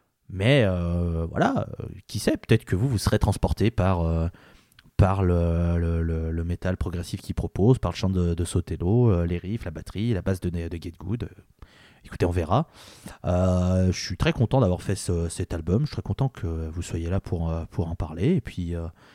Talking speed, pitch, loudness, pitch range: 210 wpm, 90 Hz, -26 LUFS, 85-105 Hz